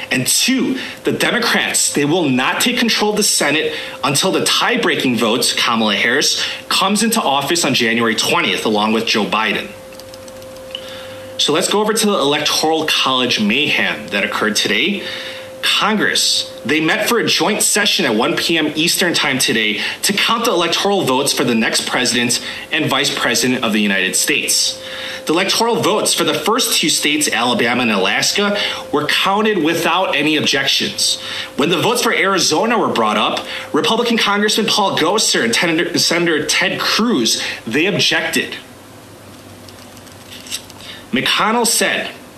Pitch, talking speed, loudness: 170 Hz, 150 wpm, -14 LUFS